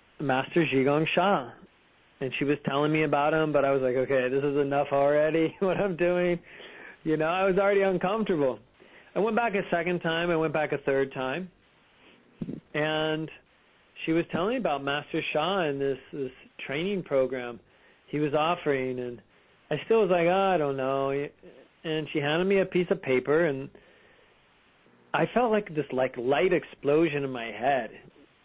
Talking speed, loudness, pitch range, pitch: 175 wpm, -27 LUFS, 135-175 Hz, 150 Hz